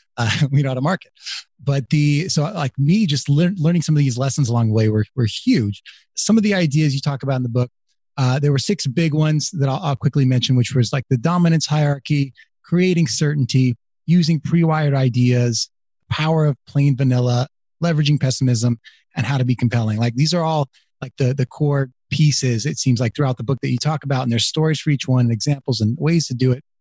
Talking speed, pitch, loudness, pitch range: 220 wpm, 140 Hz, -19 LUFS, 125-155 Hz